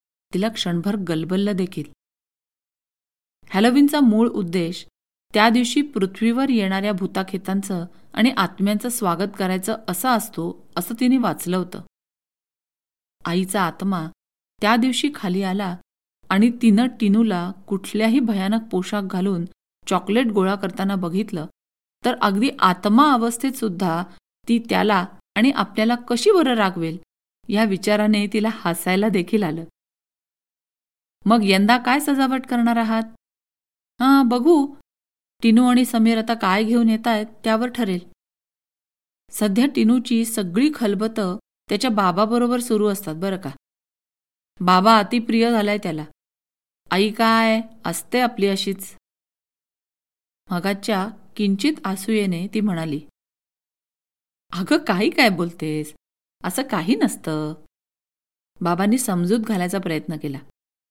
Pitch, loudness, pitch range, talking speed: 205 Hz, -20 LUFS, 180-230 Hz, 110 wpm